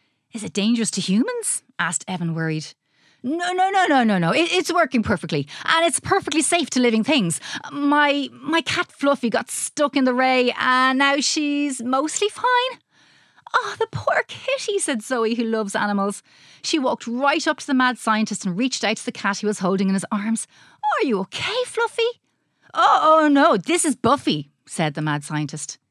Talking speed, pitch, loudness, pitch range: 190 wpm, 260 Hz, -21 LUFS, 210-325 Hz